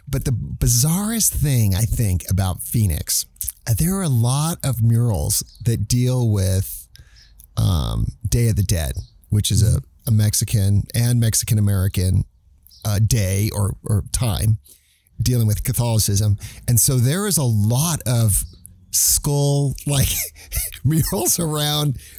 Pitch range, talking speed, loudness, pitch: 100-130 Hz, 135 wpm, -19 LUFS, 110 Hz